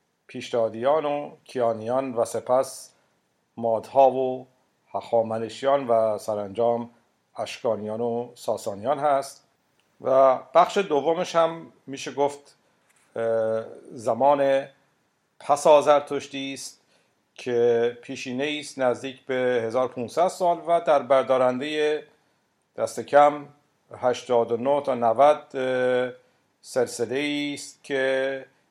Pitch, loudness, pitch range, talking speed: 130 Hz, -24 LUFS, 120-145 Hz, 90 wpm